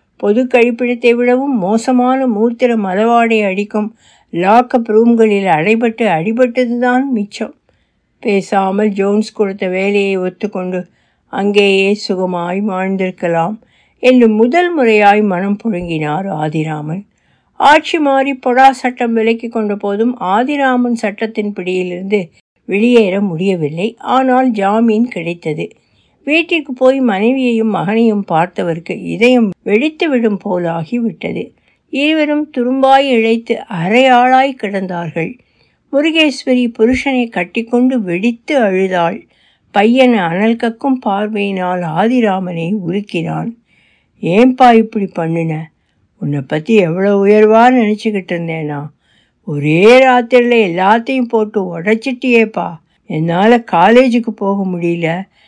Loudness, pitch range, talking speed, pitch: -13 LUFS, 185-245 Hz, 90 wpm, 215 Hz